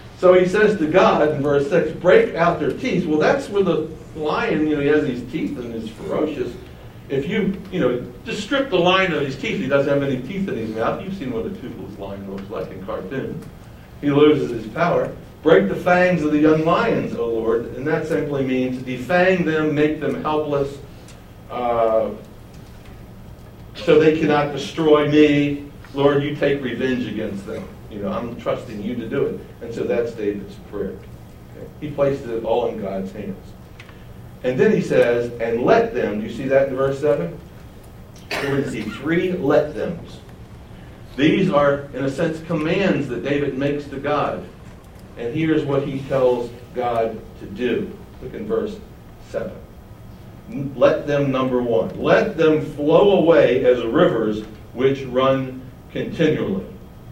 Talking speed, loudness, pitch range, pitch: 170 wpm, -20 LUFS, 125-155 Hz, 140 Hz